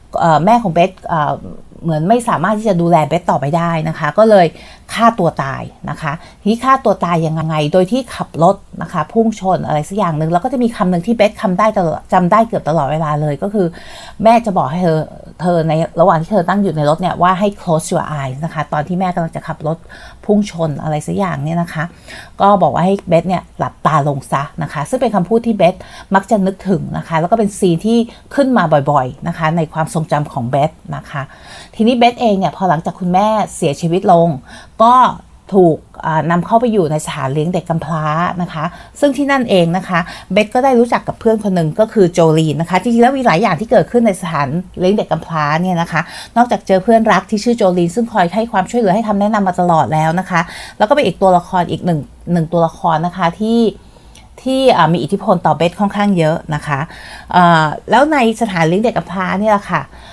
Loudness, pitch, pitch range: -14 LUFS, 180 Hz, 160-210 Hz